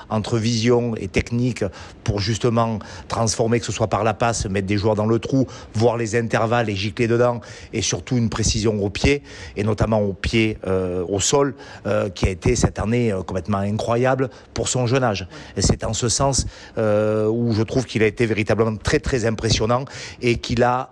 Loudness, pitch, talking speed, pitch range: -21 LUFS, 115 Hz, 200 wpm, 105-120 Hz